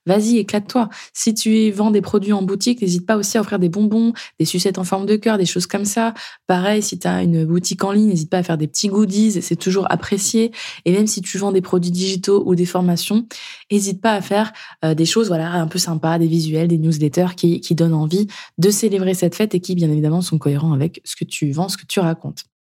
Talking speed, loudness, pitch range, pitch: 245 wpm, -18 LUFS, 170-210 Hz, 190 Hz